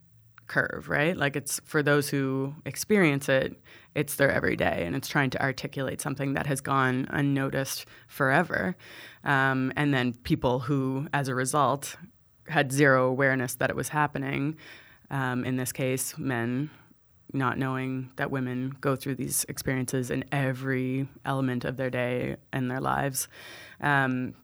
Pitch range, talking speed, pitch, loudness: 130-140 Hz, 150 wpm, 135 Hz, -28 LUFS